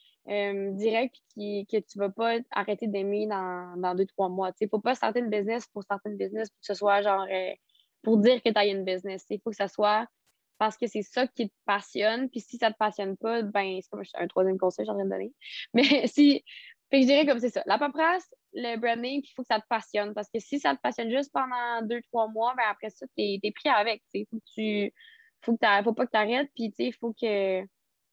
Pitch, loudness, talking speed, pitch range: 220 Hz, -28 LUFS, 270 wpm, 200-240 Hz